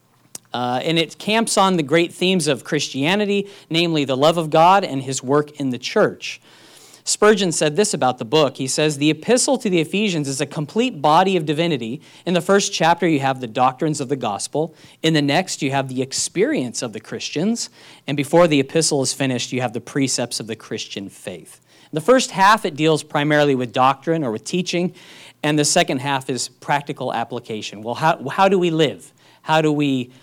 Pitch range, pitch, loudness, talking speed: 135-175 Hz, 150 Hz, -19 LUFS, 205 wpm